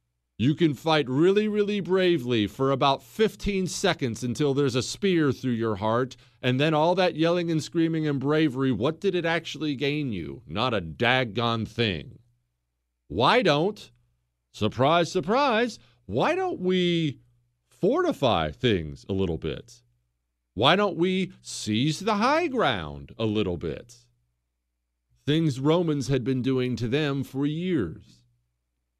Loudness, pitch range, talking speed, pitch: -25 LUFS, 100-165 Hz, 140 wpm, 135 Hz